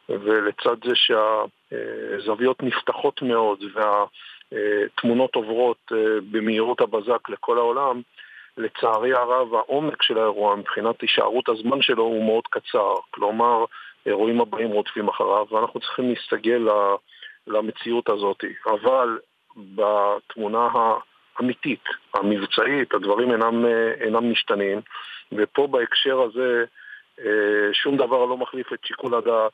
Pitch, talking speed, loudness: 125 Hz, 105 wpm, -22 LUFS